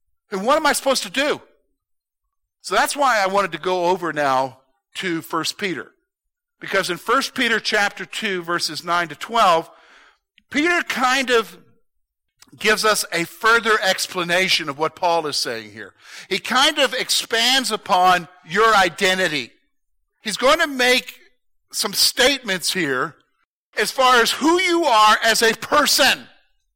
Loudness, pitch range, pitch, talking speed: -18 LUFS, 175-260 Hz, 205 Hz, 150 wpm